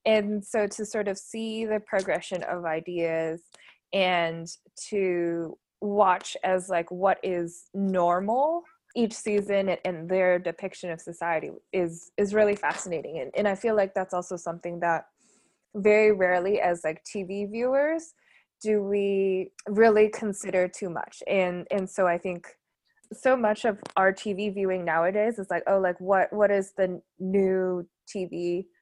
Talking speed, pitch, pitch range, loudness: 150 wpm, 195 Hz, 180-210 Hz, -27 LUFS